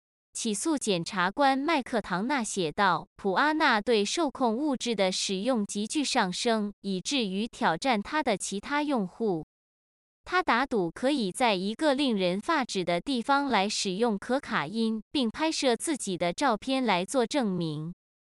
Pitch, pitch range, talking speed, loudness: 225 Hz, 195-270 Hz, 230 characters per minute, -28 LUFS